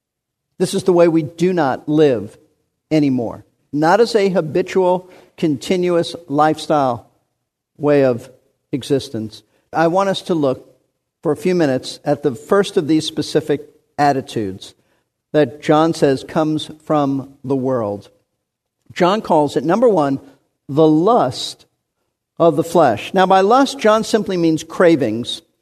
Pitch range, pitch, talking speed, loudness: 135-175 Hz, 155 Hz, 135 wpm, -17 LUFS